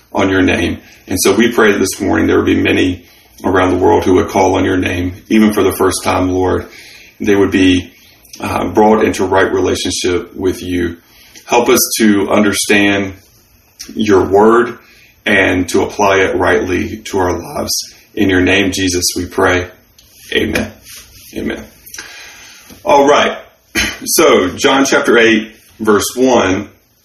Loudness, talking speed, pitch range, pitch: -12 LUFS, 150 wpm, 90-105 Hz, 95 Hz